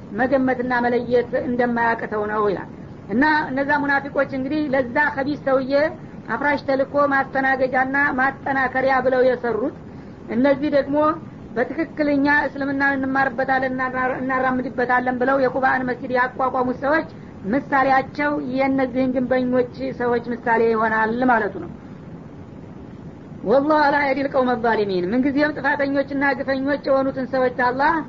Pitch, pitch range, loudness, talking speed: 265 Hz, 250-280 Hz, -20 LUFS, 105 wpm